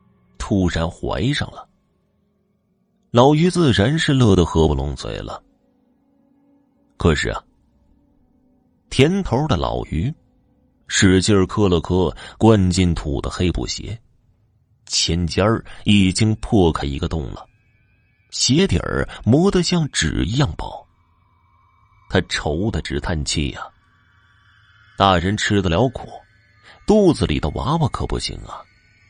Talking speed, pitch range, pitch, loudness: 165 characters per minute, 85-115 Hz, 100 Hz, -19 LUFS